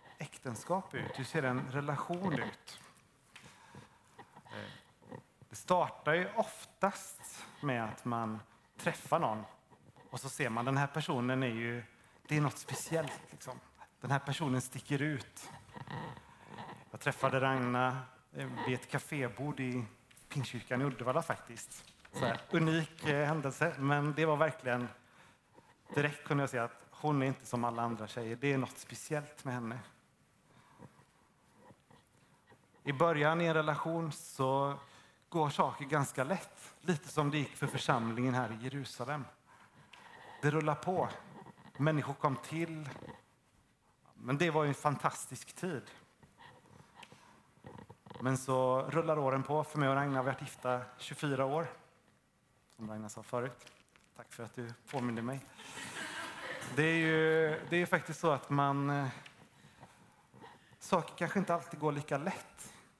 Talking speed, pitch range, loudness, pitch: 135 wpm, 125-155 Hz, -36 LUFS, 140 Hz